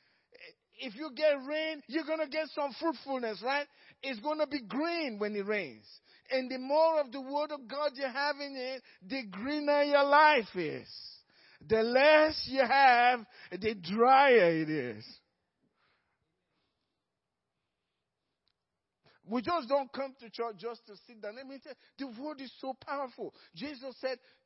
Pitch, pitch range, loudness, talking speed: 270 Hz, 235-295 Hz, -30 LUFS, 155 wpm